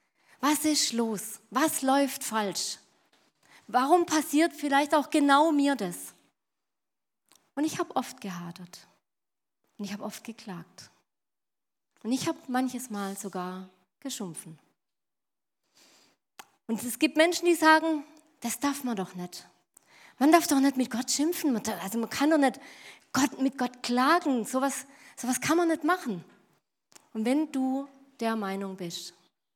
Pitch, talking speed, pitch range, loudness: 255 Hz, 140 wpm, 205-295 Hz, -27 LUFS